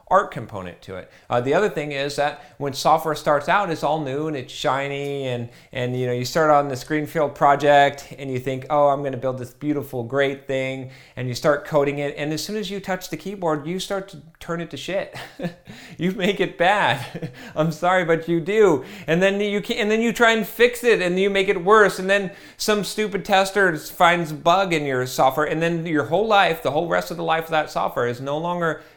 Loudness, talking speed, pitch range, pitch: -21 LUFS, 235 wpm, 140-185 Hz, 155 Hz